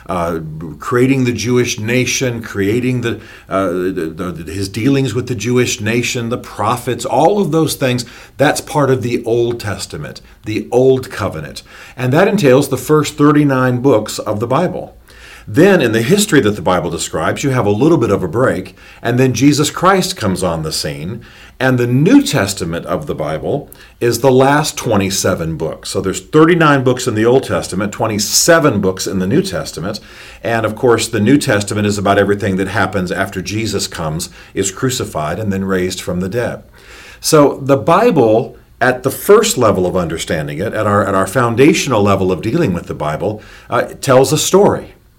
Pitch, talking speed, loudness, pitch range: 120 Hz, 180 wpm, -14 LUFS, 95-135 Hz